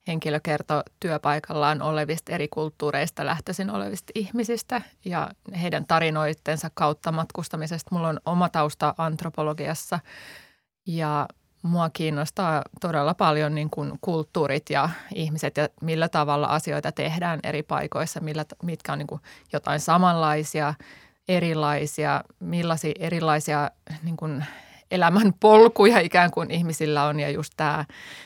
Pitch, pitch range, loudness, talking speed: 155 Hz, 150-170 Hz, -24 LUFS, 115 wpm